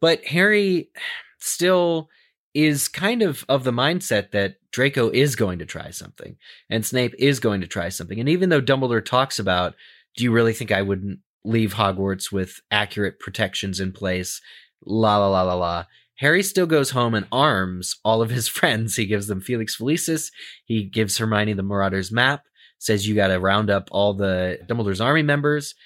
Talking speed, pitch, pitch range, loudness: 185 wpm, 110 Hz, 100-140 Hz, -21 LUFS